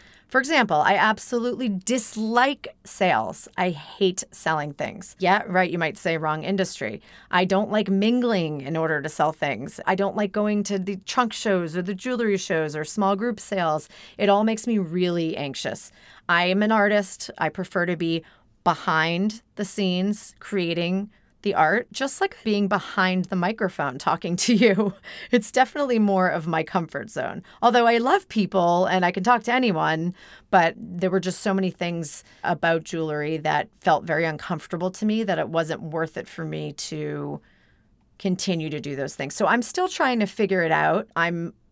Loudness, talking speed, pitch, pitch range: -24 LUFS, 180 wpm, 185 Hz, 165-210 Hz